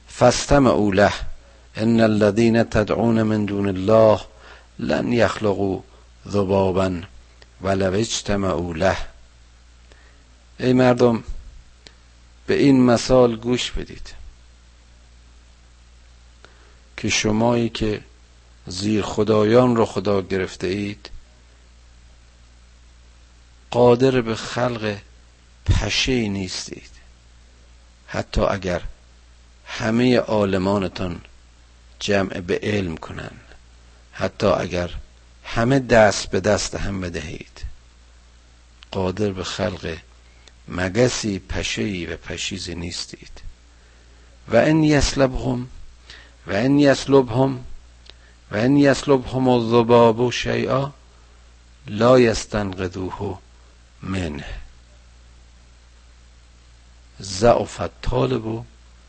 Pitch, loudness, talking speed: 85 Hz, -20 LUFS, 80 wpm